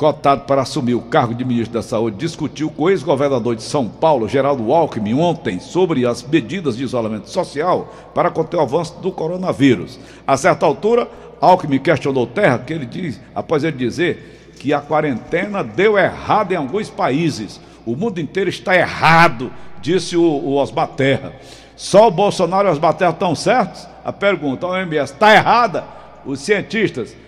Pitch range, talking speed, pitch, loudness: 130-175 Hz, 165 wpm, 155 Hz, -17 LUFS